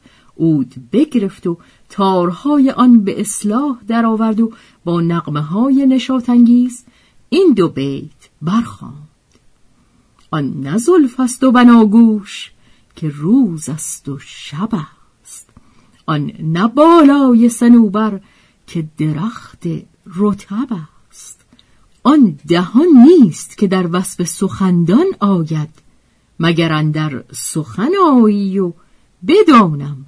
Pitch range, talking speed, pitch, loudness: 160-245 Hz, 95 wpm, 200 Hz, -13 LUFS